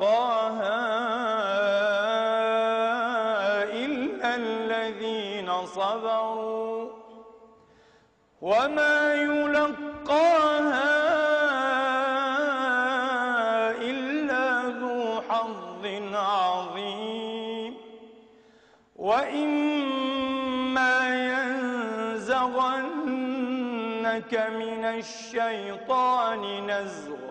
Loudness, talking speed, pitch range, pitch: -26 LUFS, 35 wpm, 225-260 Hz, 230 Hz